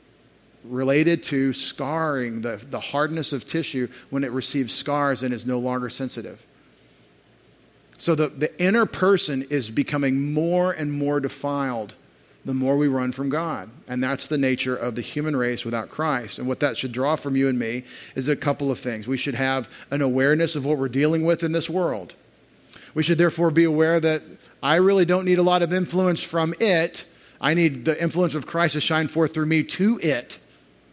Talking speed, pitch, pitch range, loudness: 195 wpm, 145 Hz, 130-165 Hz, -23 LUFS